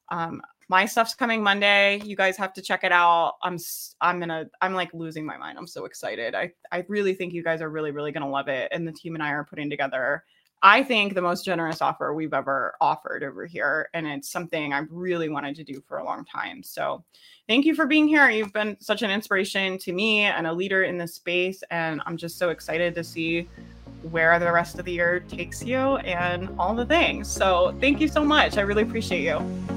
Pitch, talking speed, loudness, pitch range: 180 Hz, 230 wpm, -24 LUFS, 165-205 Hz